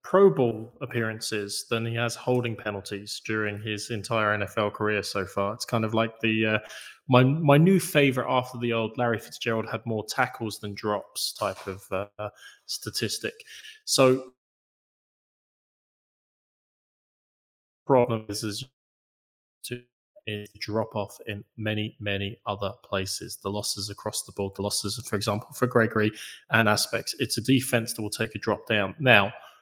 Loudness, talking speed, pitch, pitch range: -26 LUFS, 150 wpm, 110 Hz, 105-125 Hz